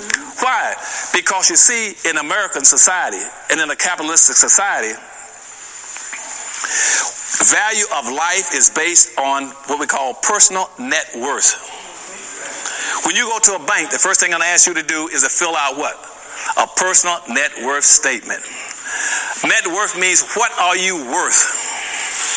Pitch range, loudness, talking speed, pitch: 155-205 Hz, -13 LUFS, 155 wpm, 180 Hz